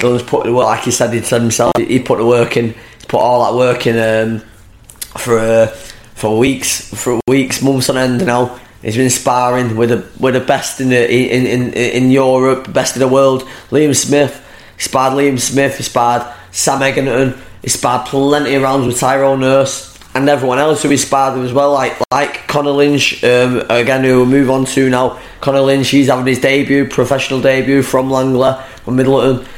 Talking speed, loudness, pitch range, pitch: 195 wpm, -12 LUFS, 120-135 Hz, 130 Hz